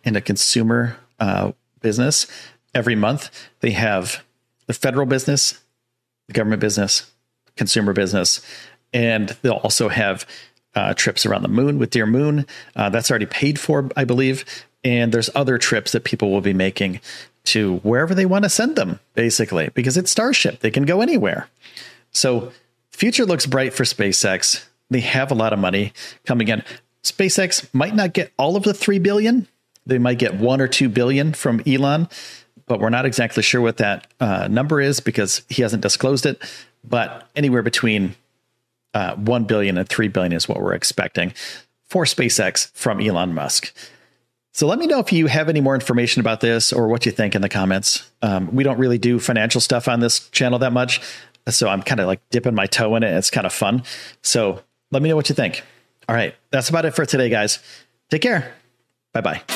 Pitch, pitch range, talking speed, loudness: 125 Hz, 110-140 Hz, 190 wpm, -19 LUFS